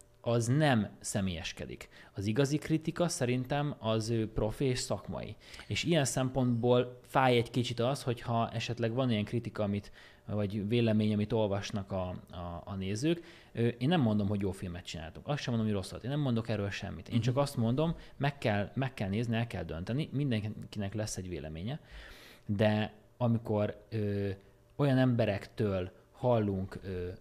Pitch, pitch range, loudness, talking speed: 115 Hz, 100-125 Hz, -33 LUFS, 160 wpm